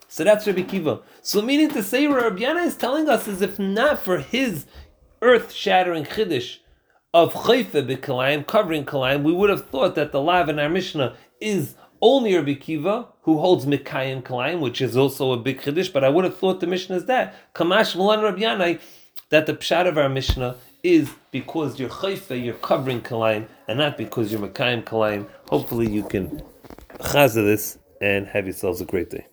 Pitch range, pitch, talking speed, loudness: 130-205 Hz, 160 Hz, 190 wpm, -21 LUFS